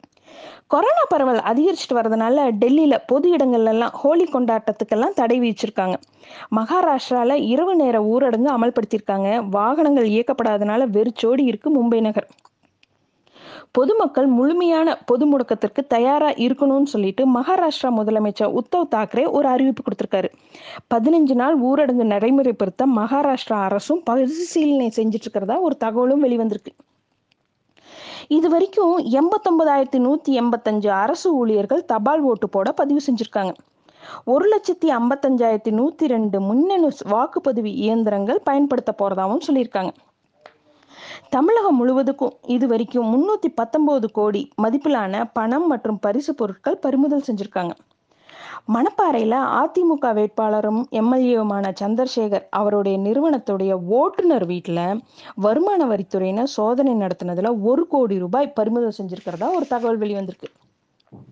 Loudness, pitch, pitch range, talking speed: -19 LUFS, 245 Hz, 220-285 Hz, 105 wpm